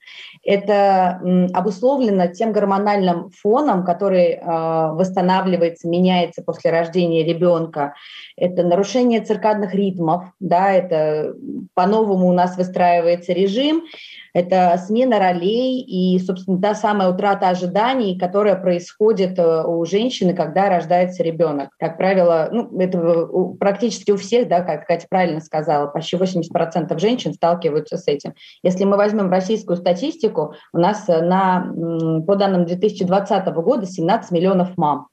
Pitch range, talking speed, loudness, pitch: 170-200 Hz, 120 wpm, -18 LUFS, 185 Hz